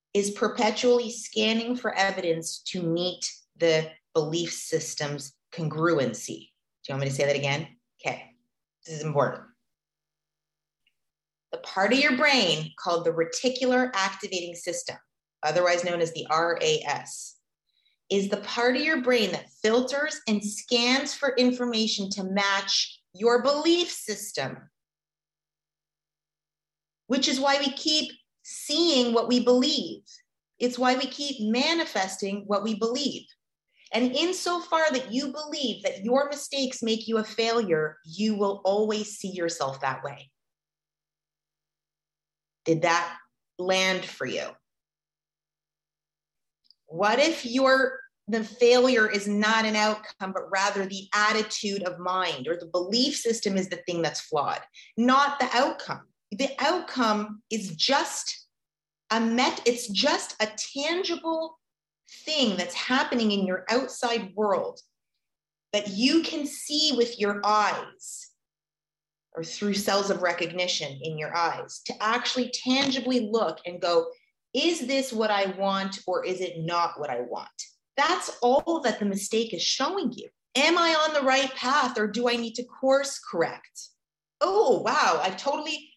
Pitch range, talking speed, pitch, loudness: 180-265 Hz, 140 wpm, 215 Hz, -26 LUFS